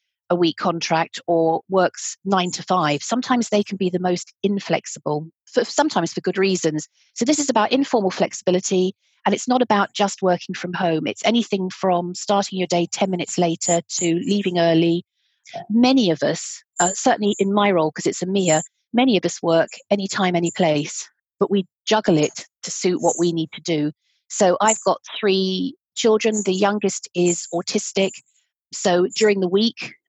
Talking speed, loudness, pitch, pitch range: 175 wpm, -20 LUFS, 185 Hz, 175-210 Hz